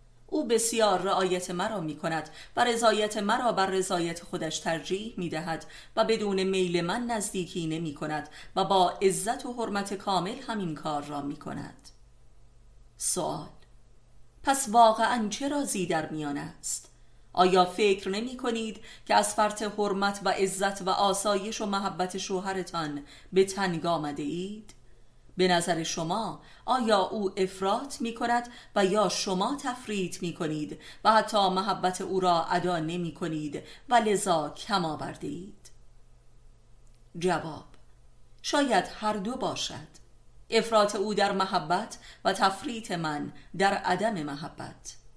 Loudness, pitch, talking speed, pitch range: -28 LUFS, 190 Hz, 135 wpm, 160-210 Hz